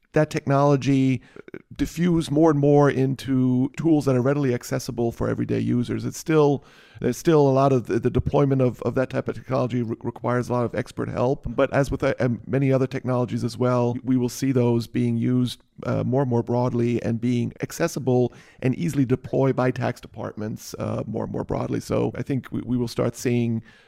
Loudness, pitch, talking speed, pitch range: -23 LUFS, 125 Hz, 200 wpm, 120-140 Hz